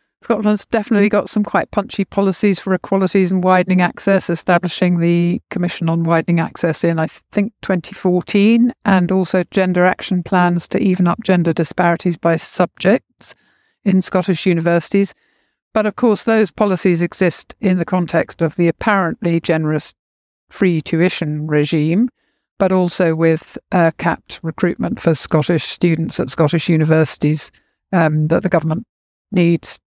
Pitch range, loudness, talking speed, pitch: 165-195 Hz, -16 LUFS, 140 wpm, 180 Hz